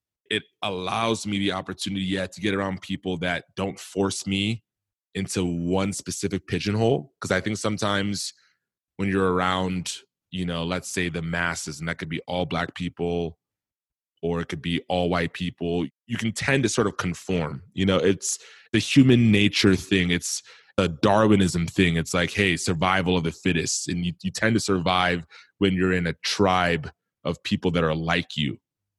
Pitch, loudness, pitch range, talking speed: 95 Hz, -25 LUFS, 85-100 Hz, 180 wpm